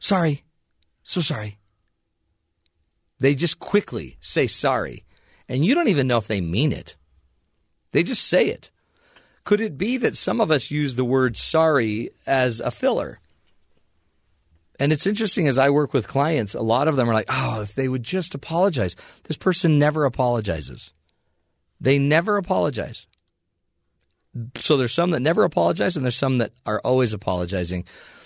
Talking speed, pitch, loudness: 160 wpm, 120 Hz, -21 LUFS